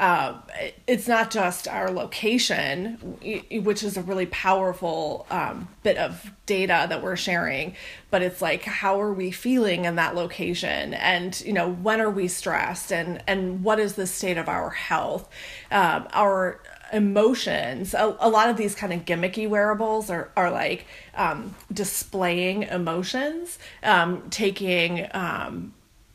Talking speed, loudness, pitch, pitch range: 150 wpm, -24 LUFS, 195 Hz, 180-215 Hz